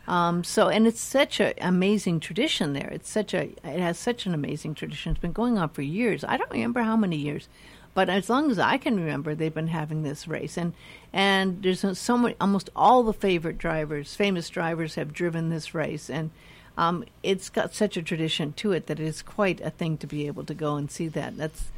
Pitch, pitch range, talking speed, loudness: 170 Hz, 155-195 Hz, 250 wpm, -26 LUFS